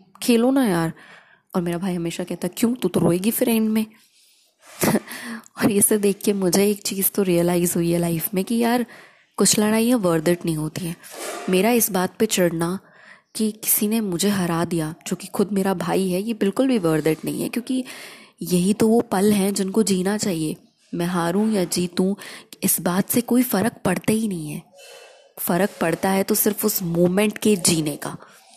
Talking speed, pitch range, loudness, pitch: 195 wpm, 175-220 Hz, -21 LUFS, 195 Hz